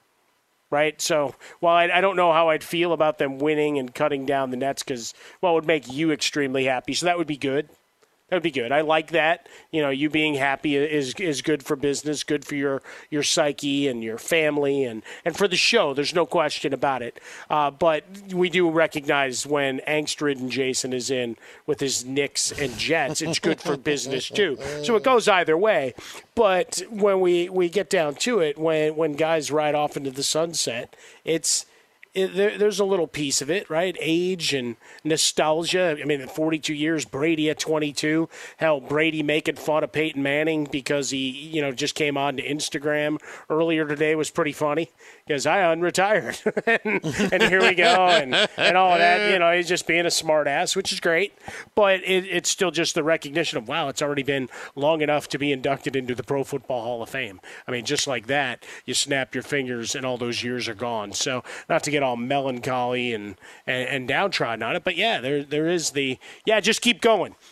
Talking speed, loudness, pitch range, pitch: 210 wpm, -23 LUFS, 140-170 Hz, 150 Hz